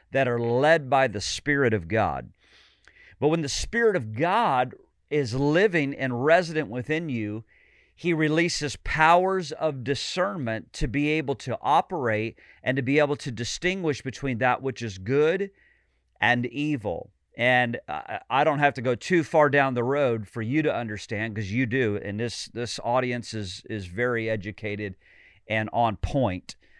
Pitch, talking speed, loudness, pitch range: 130 Hz, 160 wpm, -25 LUFS, 110-150 Hz